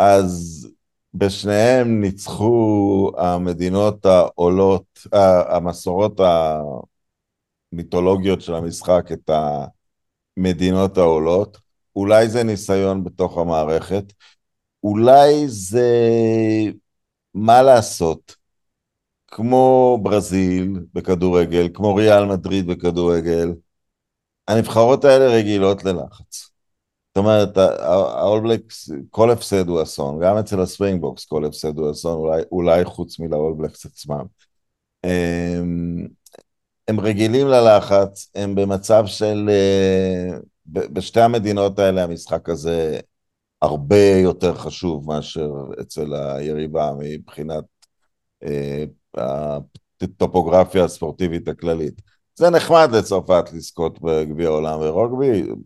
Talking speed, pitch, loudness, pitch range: 85 wpm, 95 Hz, -17 LUFS, 85-105 Hz